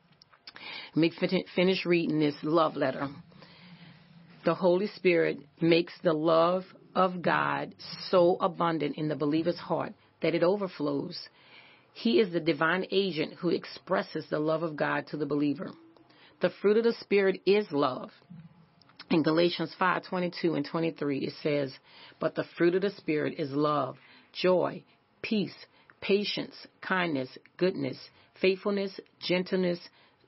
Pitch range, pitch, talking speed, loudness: 150-180 Hz, 170 Hz, 135 wpm, -29 LUFS